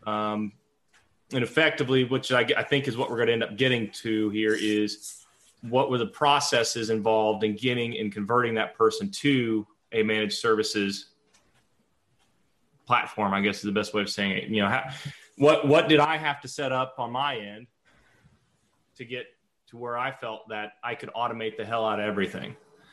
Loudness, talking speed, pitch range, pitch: -26 LUFS, 190 wpm, 105-130 Hz, 115 Hz